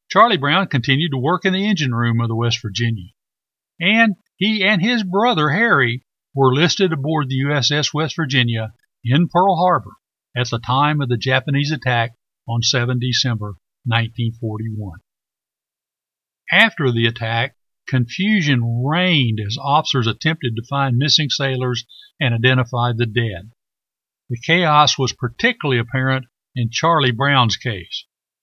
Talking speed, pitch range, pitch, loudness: 135 wpm, 120-155 Hz, 130 Hz, -17 LUFS